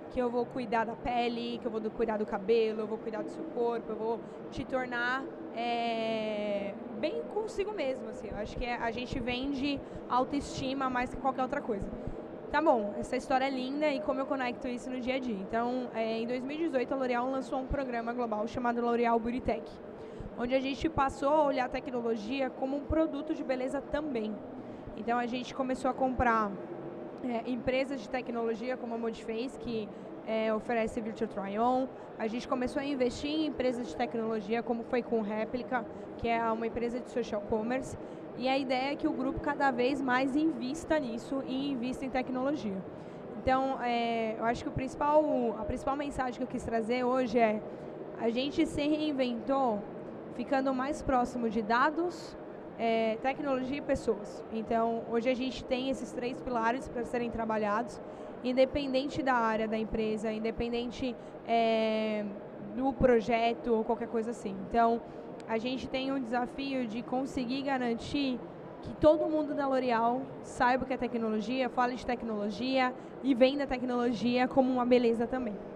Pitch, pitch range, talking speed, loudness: 245 Hz, 230-265 Hz, 175 wpm, -32 LUFS